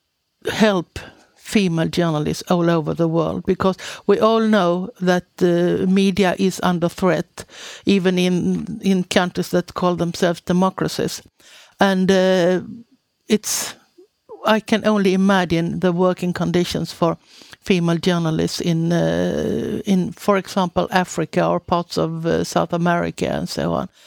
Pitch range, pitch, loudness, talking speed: 175-195 Hz, 180 Hz, -19 LUFS, 130 wpm